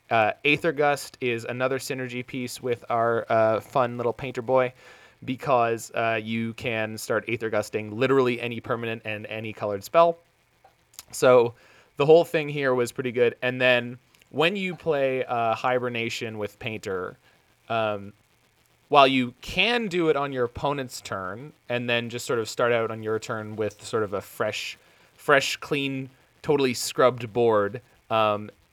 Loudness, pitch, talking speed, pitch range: -25 LUFS, 120 Hz, 160 wpm, 115-135 Hz